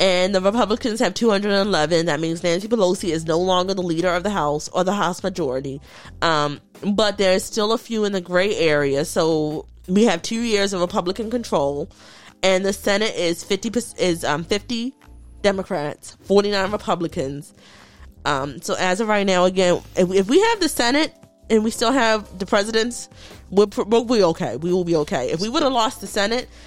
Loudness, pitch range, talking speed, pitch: -20 LUFS, 170-220 Hz, 200 wpm, 195 Hz